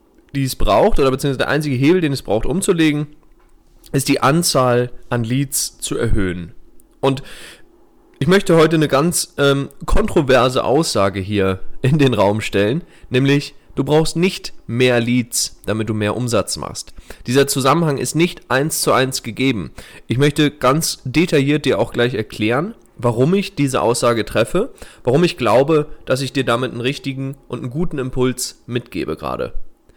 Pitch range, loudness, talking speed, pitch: 120-150 Hz, -17 LUFS, 160 wpm, 135 Hz